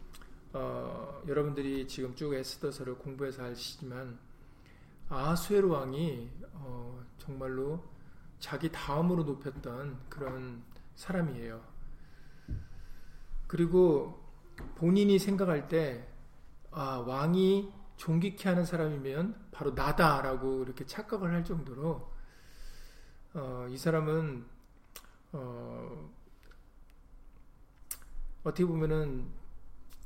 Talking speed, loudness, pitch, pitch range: 195 characters per minute, -33 LUFS, 140 Hz, 130-165 Hz